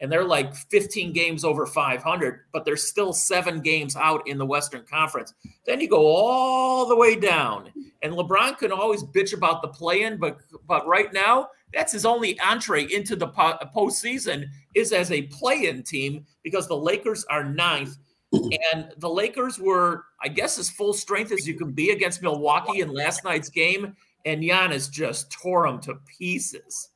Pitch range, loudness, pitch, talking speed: 150-205 Hz, -23 LUFS, 175 Hz, 175 wpm